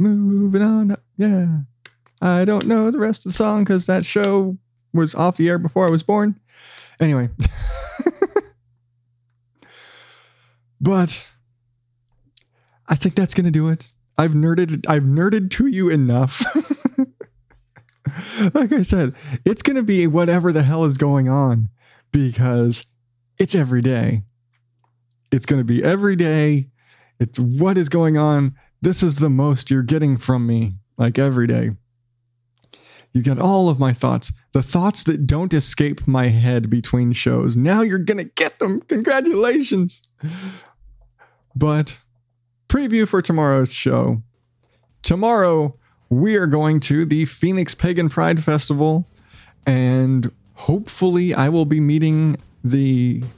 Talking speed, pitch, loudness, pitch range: 135 wpm, 145 Hz, -18 LUFS, 120-180 Hz